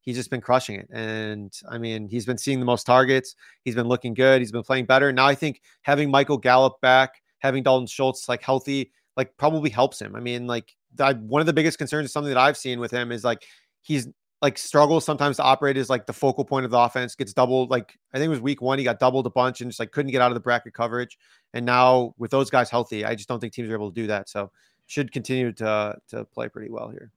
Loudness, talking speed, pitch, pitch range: -23 LUFS, 260 wpm, 125 Hz, 120-135 Hz